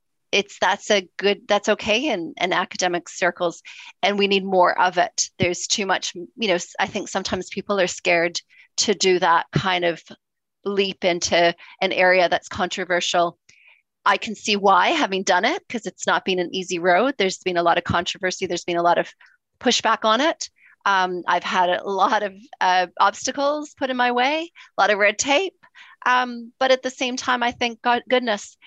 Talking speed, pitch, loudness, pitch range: 195 wpm, 195 Hz, -21 LUFS, 180-240 Hz